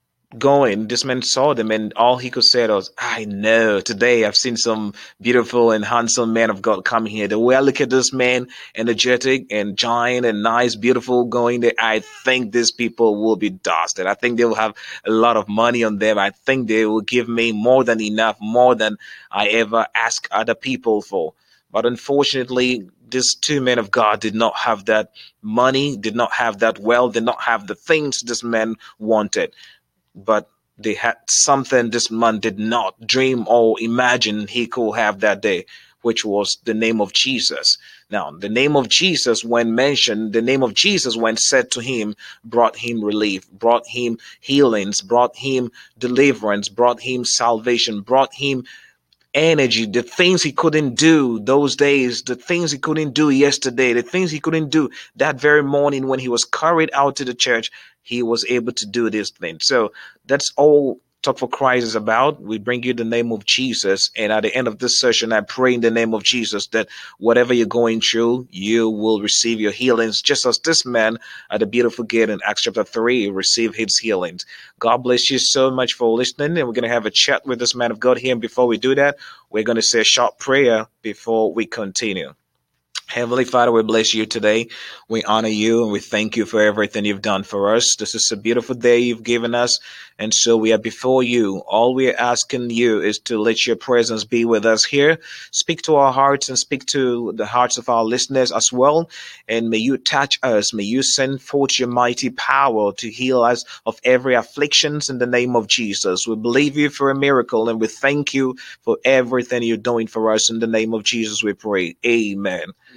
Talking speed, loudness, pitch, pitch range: 205 wpm, -17 LUFS, 120 Hz, 110-130 Hz